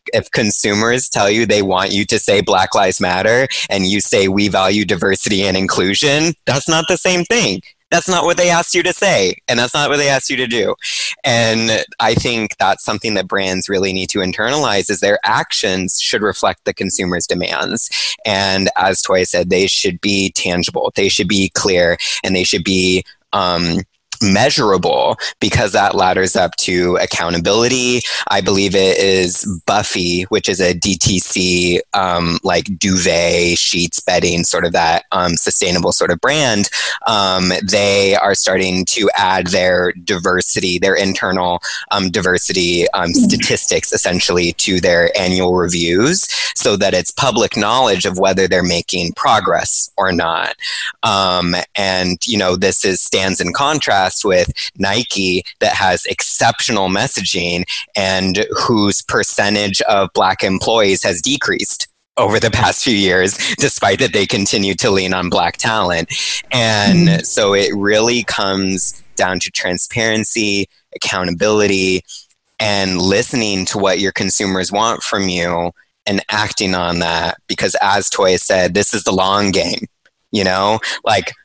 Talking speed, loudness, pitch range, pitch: 155 wpm, -13 LUFS, 90-105 Hz, 95 Hz